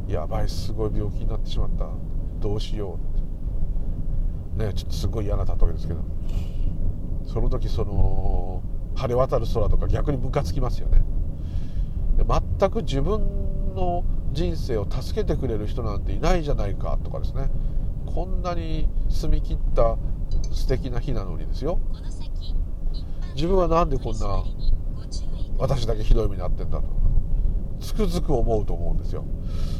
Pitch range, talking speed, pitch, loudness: 80-105 Hz, 295 characters per minute, 90 Hz, -28 LUFS